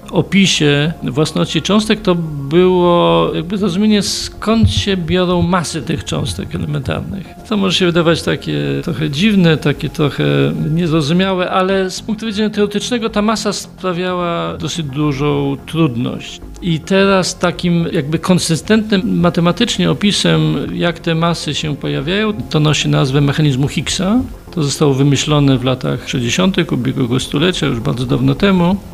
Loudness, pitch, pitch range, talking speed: -15 LUFS, 170 Hz, 145-190 Hz, 135 wpm